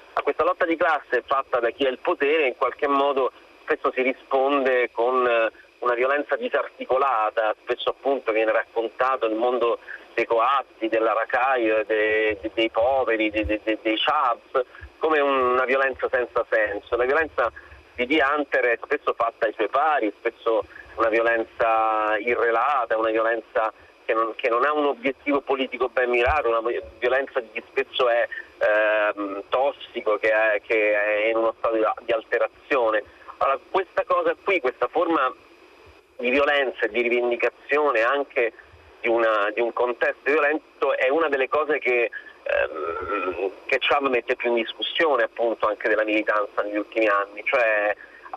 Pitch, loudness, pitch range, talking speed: 120 Hz, -23 LUFS, 110-140 Hz, 150 wpm